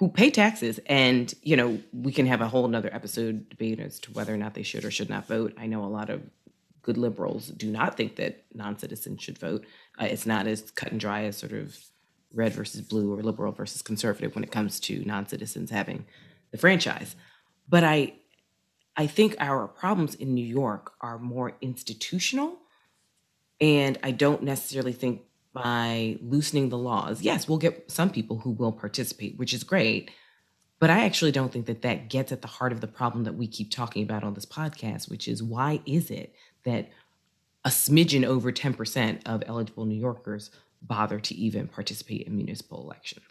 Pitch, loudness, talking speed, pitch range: 120 Hz, -27 LUFS, 195 wpm, 110-140 Hz